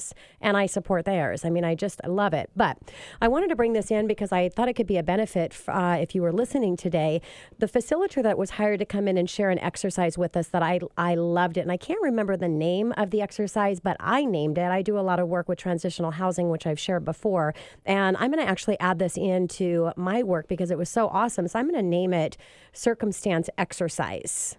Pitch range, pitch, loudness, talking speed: 175-210 Hz, 185 Hz, -26 LUFS, 240 wpm